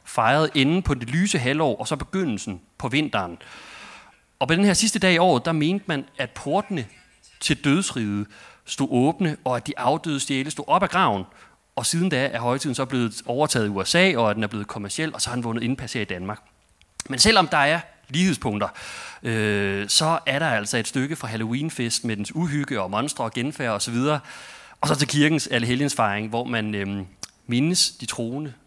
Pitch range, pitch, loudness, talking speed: 115-155 Hz, 130 Hz, -23 LUFS, 205 wpm